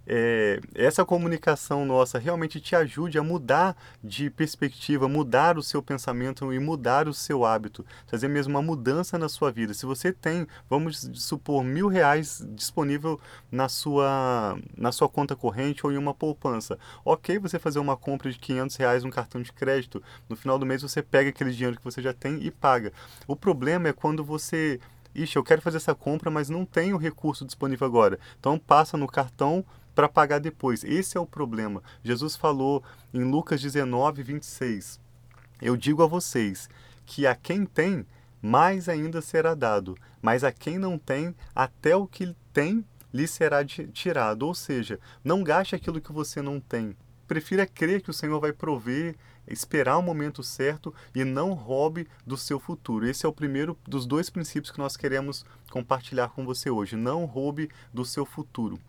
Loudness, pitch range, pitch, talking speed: -27 LUFS, 125-160 Hz, 140 Hz, 180 wpm